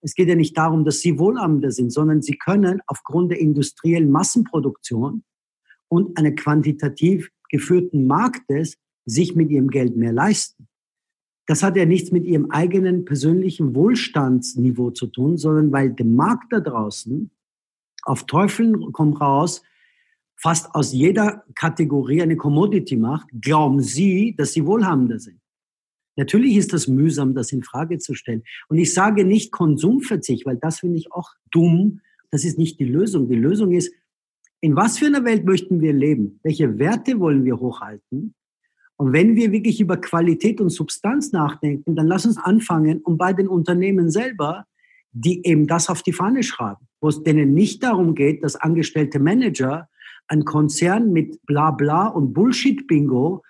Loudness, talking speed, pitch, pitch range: -19 LUFS, 160 wpm, 165 Hz, 145-190 Hz